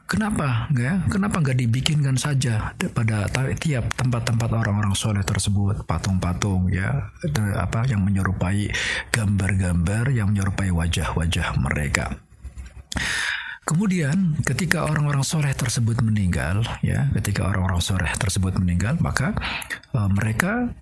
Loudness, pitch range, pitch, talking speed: -23 LUFS, 95-135 Hz, 110 Hz, 110 wpm